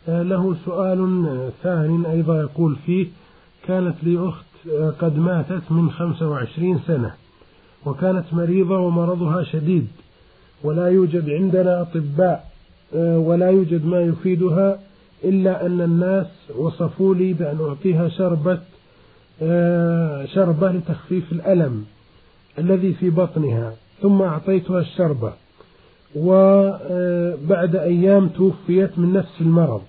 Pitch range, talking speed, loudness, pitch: 160-185 Hz, 100 wpm, -19 LUFS, 175 Hz